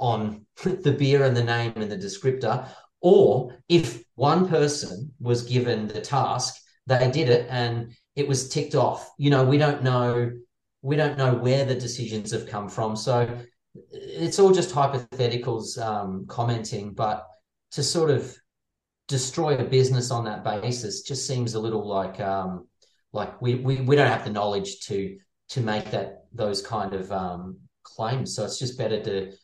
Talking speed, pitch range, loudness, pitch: 175 wpm, 105-135 Hz, -25 LUFS, 120 Hz